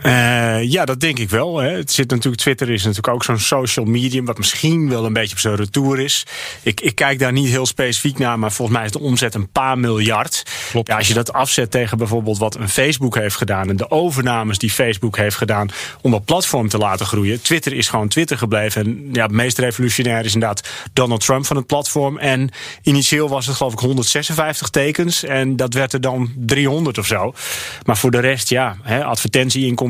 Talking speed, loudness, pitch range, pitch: 215 wpm, -17 LUFS, 115-135 Hz, 125 Hz